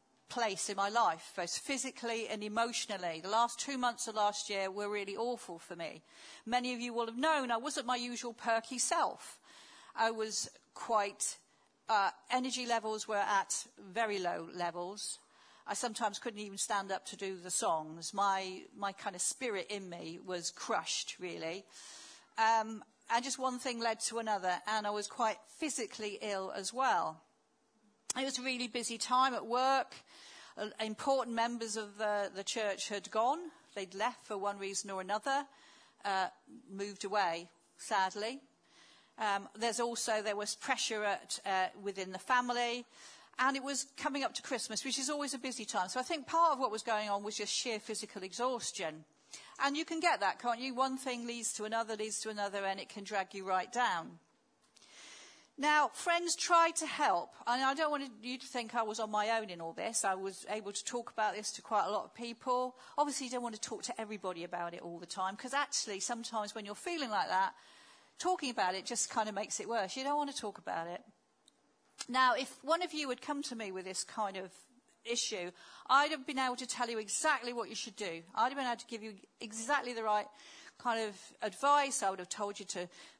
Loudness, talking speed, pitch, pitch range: -36 LUFS, 205 wpm, 225 Hz, 205-260 Hz